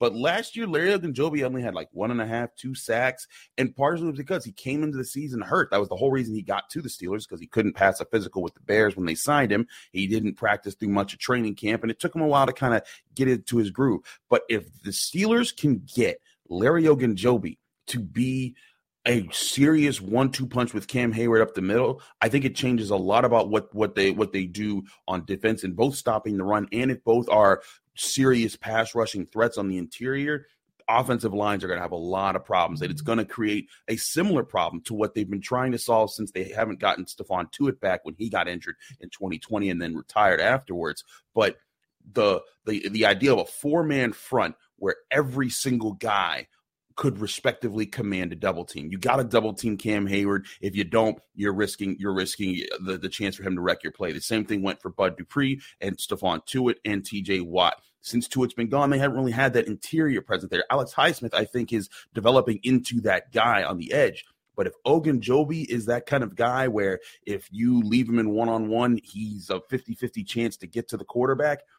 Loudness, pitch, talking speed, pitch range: -25 LUFS, 115 Hz, 220 wpm, 100-130 Hz